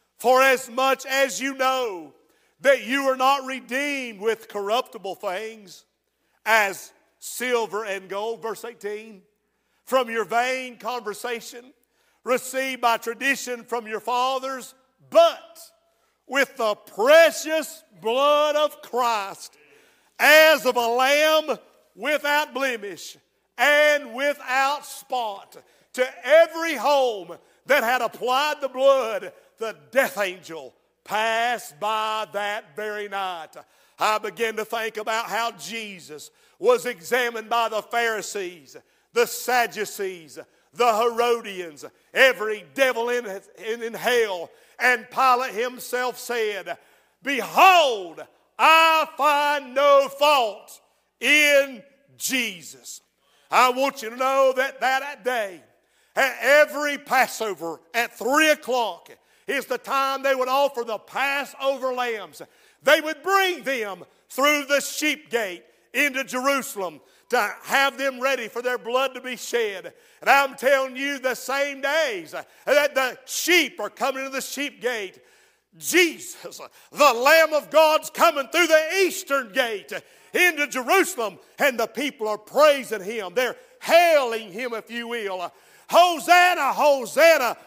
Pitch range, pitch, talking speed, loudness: 230-290 Hz, 260 Hz, 125 wpm, -22 LUFS